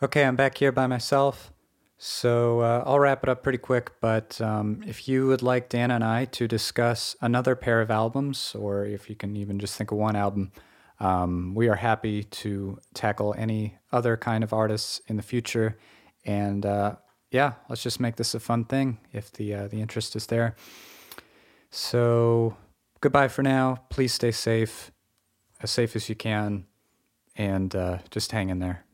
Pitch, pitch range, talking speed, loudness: 110 Hz, 105-120 Hz, 180 wpm, -26 LUFS